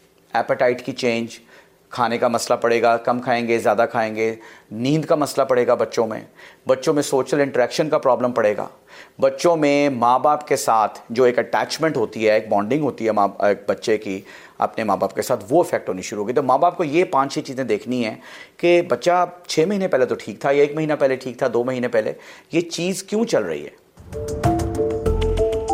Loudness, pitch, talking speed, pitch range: -20 LUFS, 130 Hz, 205 wpm, 115-160 Hz